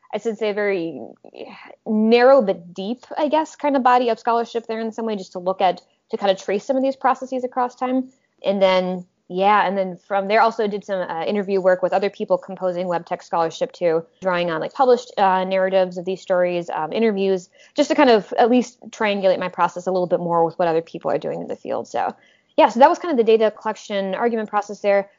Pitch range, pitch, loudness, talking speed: 185-235 Hz, 200 Hz, -20 LUFS, 240 wpm